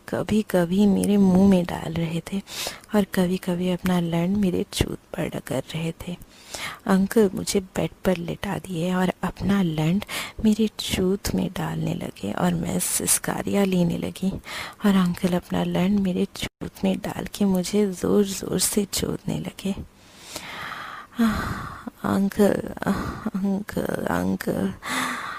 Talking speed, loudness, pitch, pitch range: 130 wpm, -24 LUFS, 190 Hz, 180-205 Hz